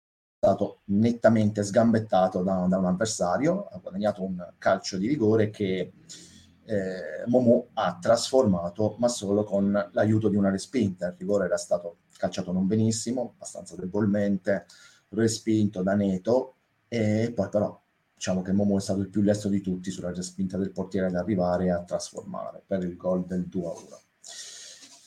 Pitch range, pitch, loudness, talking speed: 95-110 Hz, 100 Hz, -26 LUFS, 155 wpm